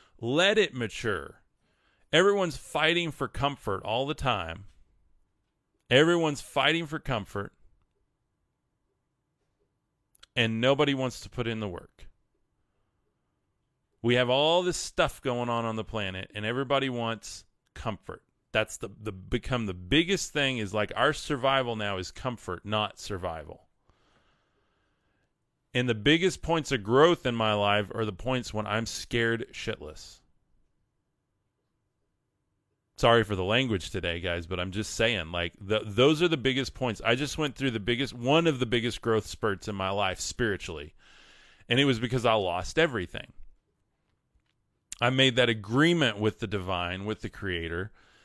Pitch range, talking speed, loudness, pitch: 100-135 Hz, 145 wpm, -28 LUFS, 115 Hz